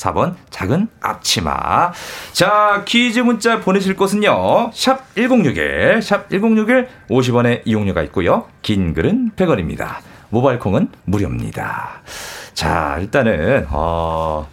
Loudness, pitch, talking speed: -16 LUFS, 200 Hz, 205 characters per minute